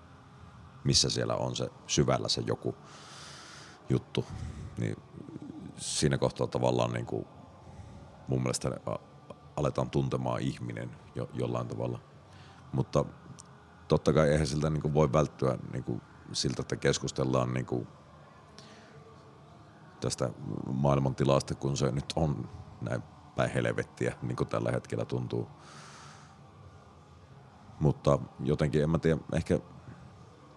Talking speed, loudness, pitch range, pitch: 110 wpm, -31 LUFS, 60-75 Hz, 65 Hz